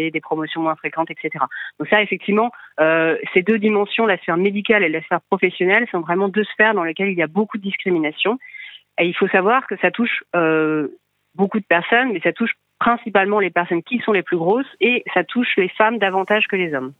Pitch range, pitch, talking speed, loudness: 170-220 Hz, 195 Hz, 220 wpm, -18 LUFS